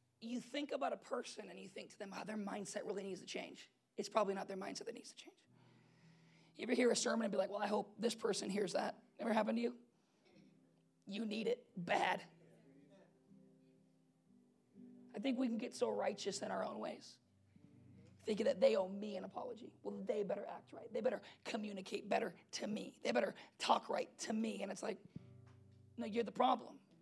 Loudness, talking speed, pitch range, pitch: -41 LUFS, 205 wpm, 190-235 Hz, 210 Hz